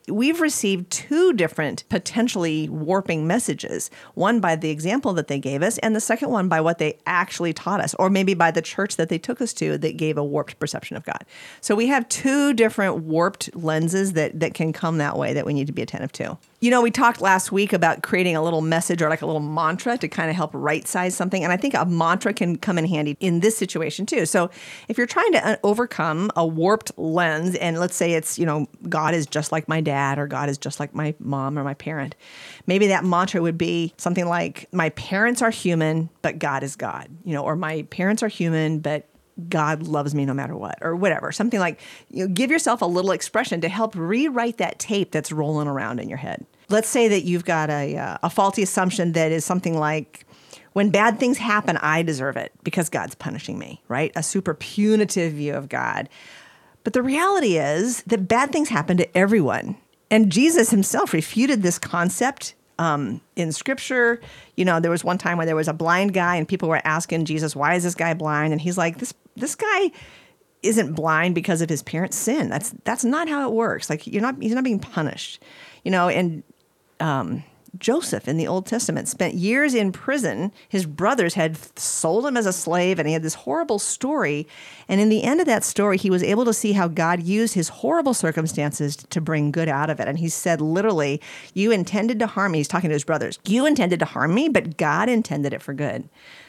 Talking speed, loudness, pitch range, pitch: 220 wpm, -22 LUFS, 155-215 Hz, 175 Hz